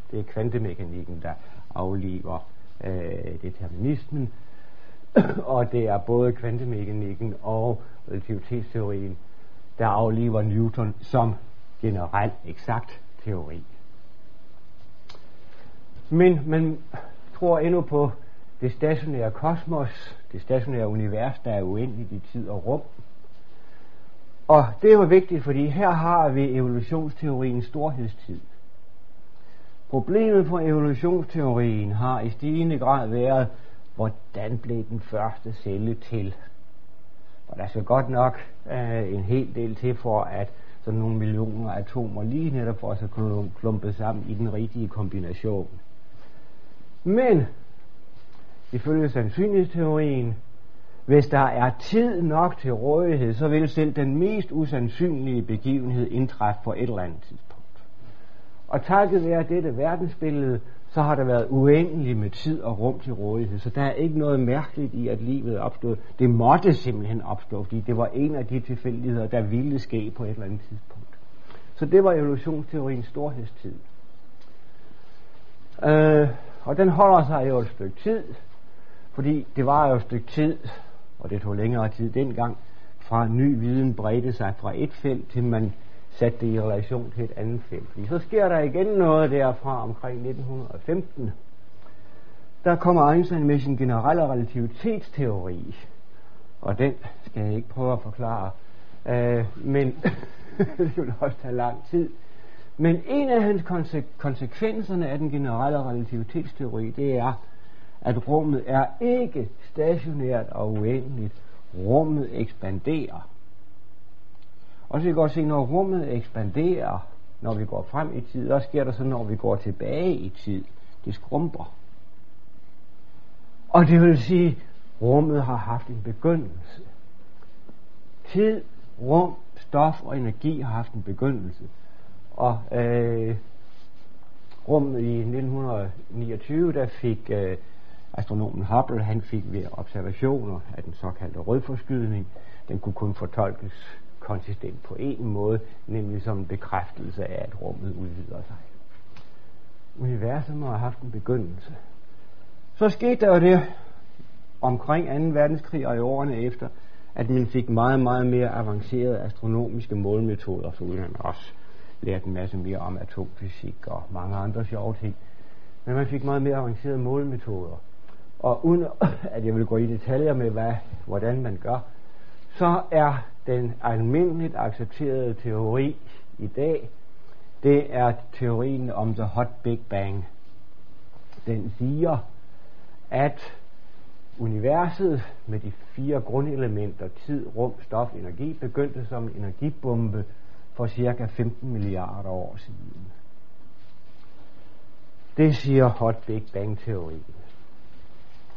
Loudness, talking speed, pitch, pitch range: -25 LUFS, 135 wpm, 115 Hz, 105-135 Hz